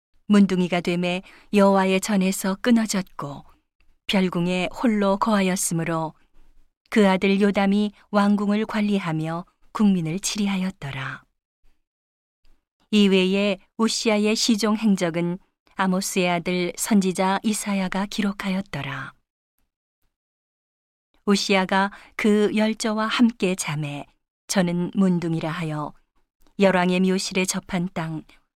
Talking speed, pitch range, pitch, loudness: 230 characters per minute, 180-205 Hz, 195 Hz, -22 LUFS